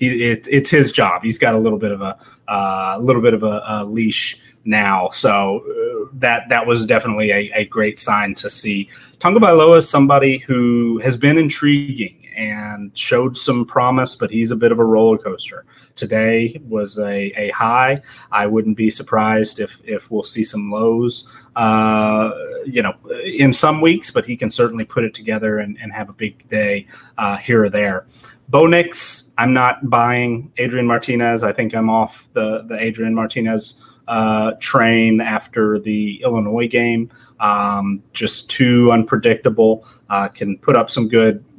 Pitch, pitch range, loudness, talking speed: 115 Hz, 105-125 Hz, -16 LUFS, 170 wpm